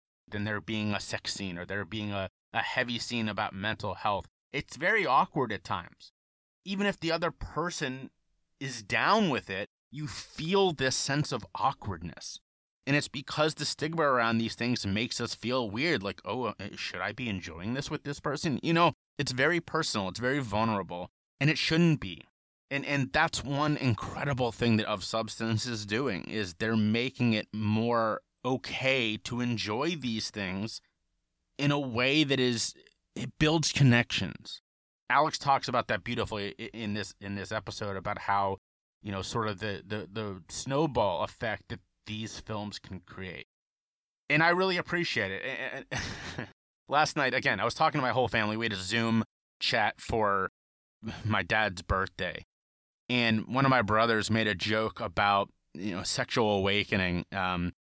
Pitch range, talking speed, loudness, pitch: 105-135 Hz, 170 wpm, -30 LUFS, 115 Hz